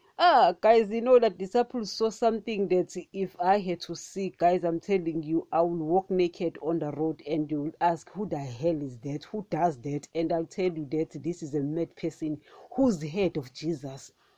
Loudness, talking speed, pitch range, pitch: -28 LUFS, 215 wpm, 160-195 Hz, 170 Hz